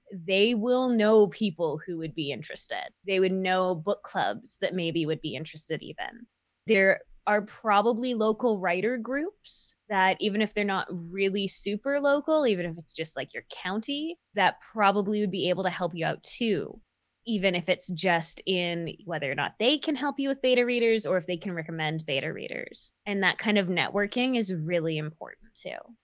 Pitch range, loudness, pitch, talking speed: 175-230 Hz, -27 LUFS, 195 Hz, 185 wpm